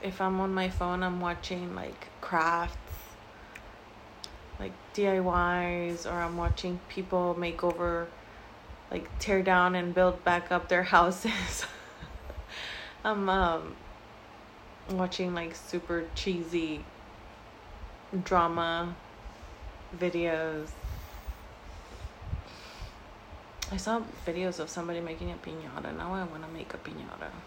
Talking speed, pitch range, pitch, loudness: 105 wpm, 170-185 Hz, 175 Hz, -31 LUFS